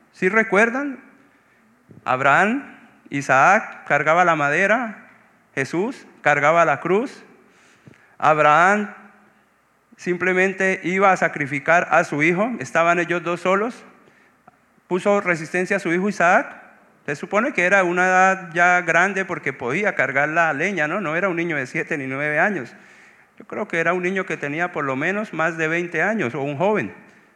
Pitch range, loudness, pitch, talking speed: 160-200 Hz, -19 LUFS, 180 Hz, 155 wpm